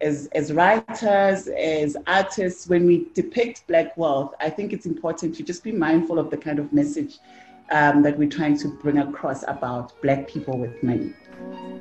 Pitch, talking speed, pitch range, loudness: 160 Hz, 180 wpm, 145-190 Hz, -22 LUFS